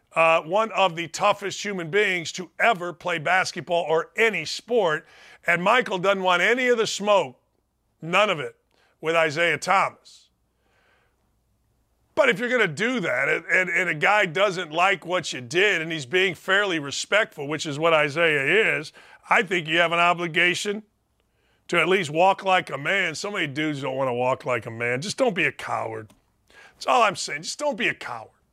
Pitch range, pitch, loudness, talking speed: 160-200 Hz, 180 Hz, -22 LUFS, 195 wpm